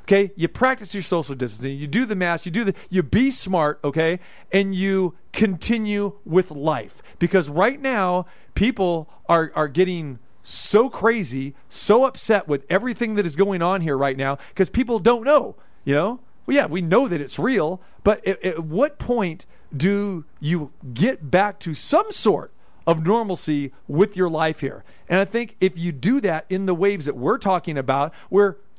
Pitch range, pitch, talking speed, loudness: 160-205 Hz, 185 Hz, 185 wpm, -21 LUFS